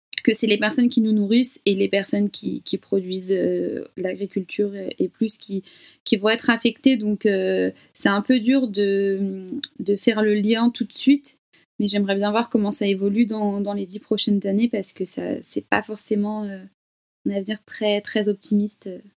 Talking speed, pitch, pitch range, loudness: 190 wpm, 210 Hz, 200-230 Hz, -22 LUFS